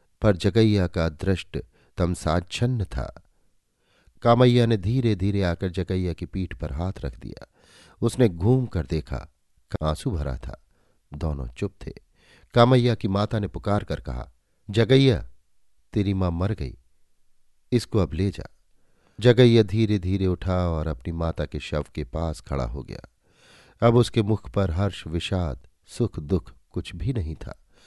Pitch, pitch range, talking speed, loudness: 95 Hz, 80-110 Hz, 150 wpm, -24 LUFS